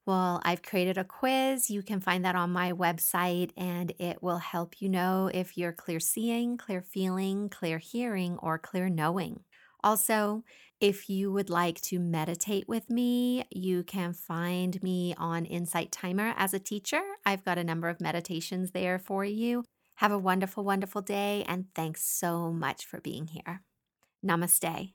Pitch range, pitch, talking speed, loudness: 175-205 Hz, 185 Hz, 170 wpm, -31 LUFS